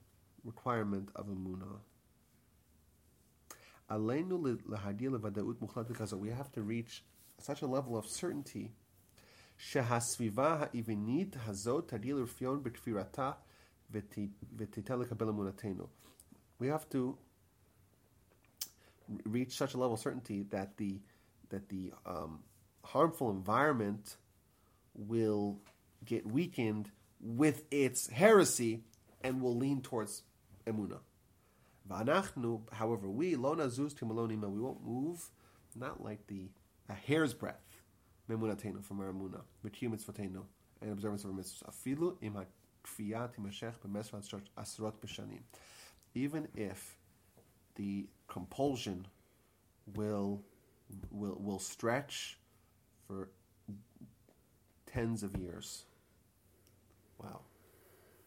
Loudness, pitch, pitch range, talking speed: -38 LUFS, 105 Hz, 100-120 Hz, 90 wpm